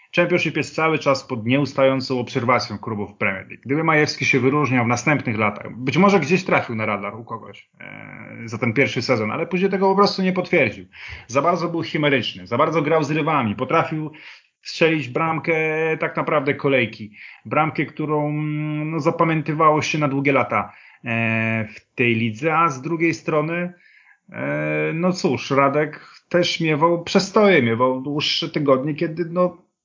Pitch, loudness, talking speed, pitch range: 150 Hz, -20 LUFS, 165 wpm, 125-165 Hz